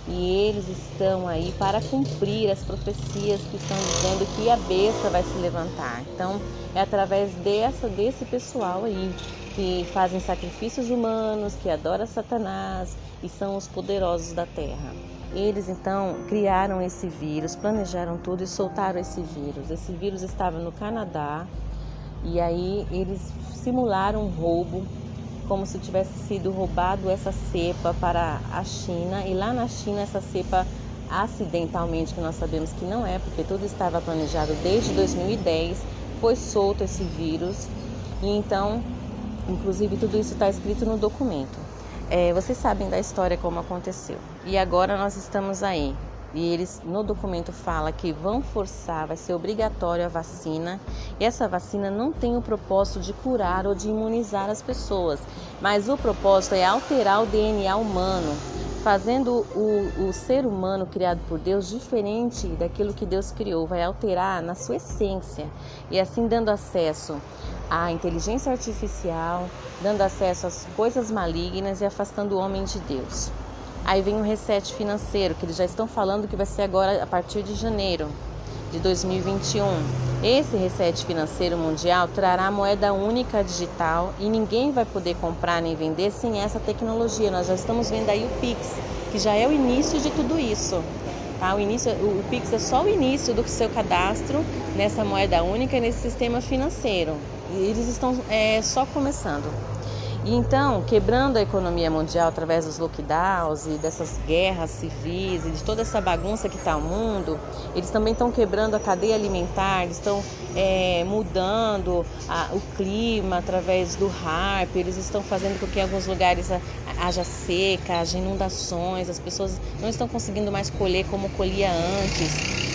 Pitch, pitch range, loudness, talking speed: 190 Hz, 170-210 Hz, -25 LUFS, 160 wpm